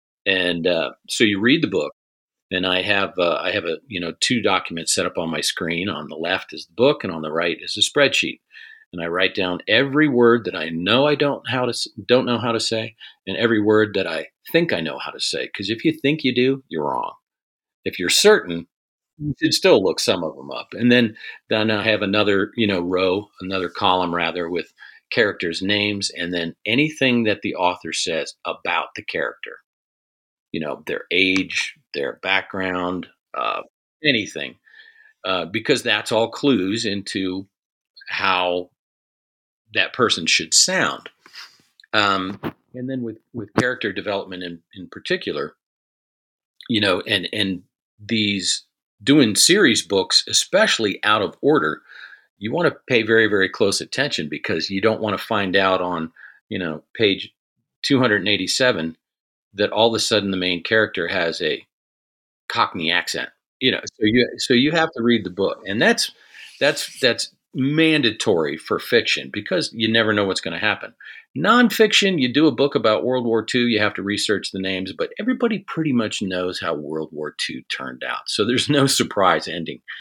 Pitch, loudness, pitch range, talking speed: 105 Hz, -20 LUFS, 90-130 Hz, 180 wpm